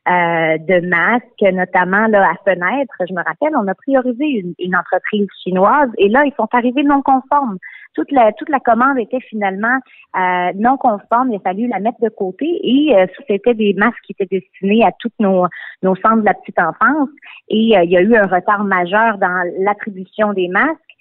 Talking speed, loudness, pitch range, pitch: 205 wpm, -15 LUFS, 190-250 Hz, 210 Hz